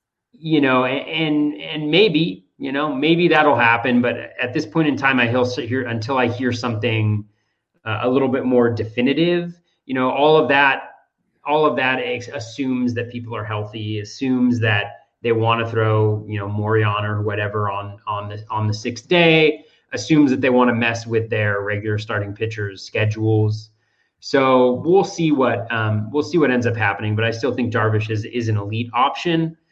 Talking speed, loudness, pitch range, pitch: 190 wpm, -19 LUFS, 110-140 Hz, 120 Hz